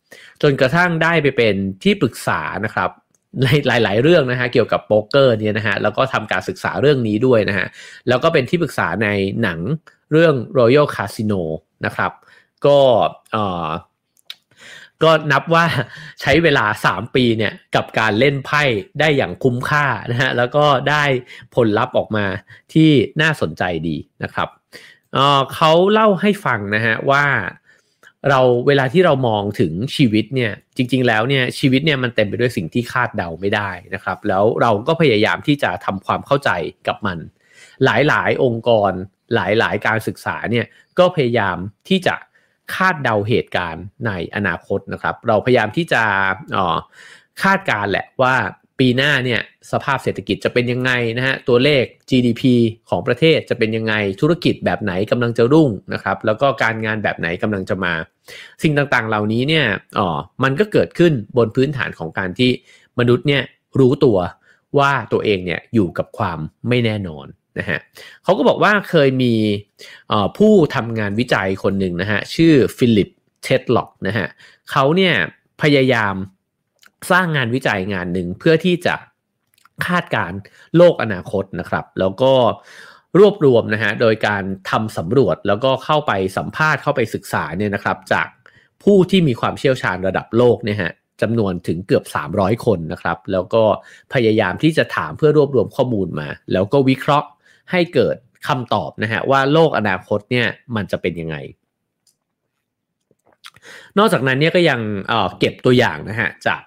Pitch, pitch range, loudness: 125 Hz, 105-145 Hz, -17 LUFS